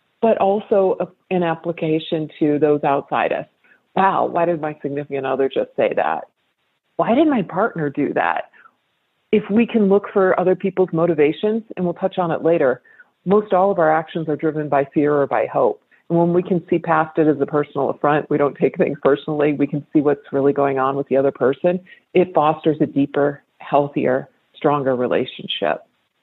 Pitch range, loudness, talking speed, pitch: 145-180 Hz, -19 LUFS, 190 wpm, 160 Hz